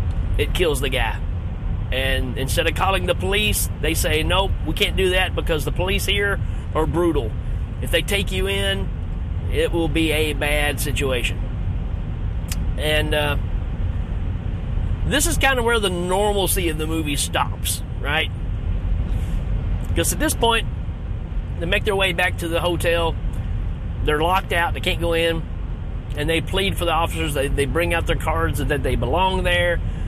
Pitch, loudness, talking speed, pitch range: 90 Hz, -22 LUFS, 165 wpm, 85-100 Hz